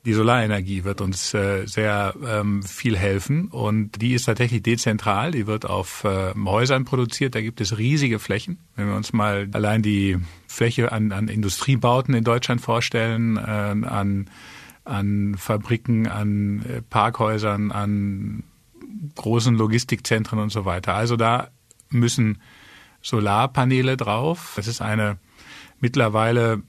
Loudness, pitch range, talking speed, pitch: -22 LUFS, 105-120 Hz, 125 wpm, 110 Hz